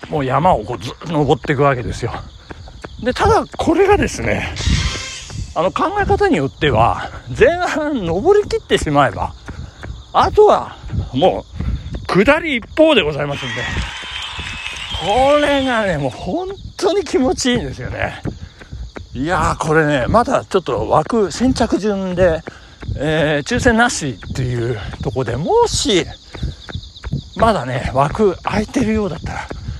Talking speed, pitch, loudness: 260 characters per minute, 190 Hz, -17 LUFS